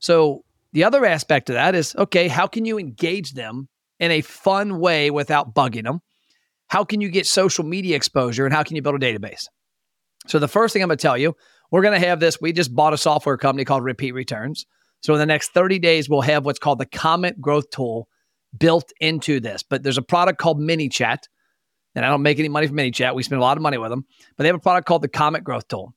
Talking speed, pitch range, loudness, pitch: 245 wpm, 135-175 Hz, -19 LUFS, 155 Hz